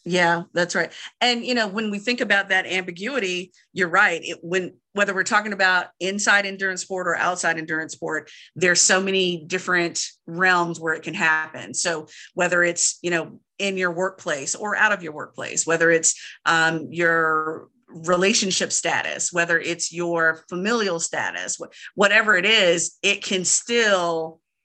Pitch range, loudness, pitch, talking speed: 165-195 Hz, -21 LUFS, 180 Hz, 160 wpm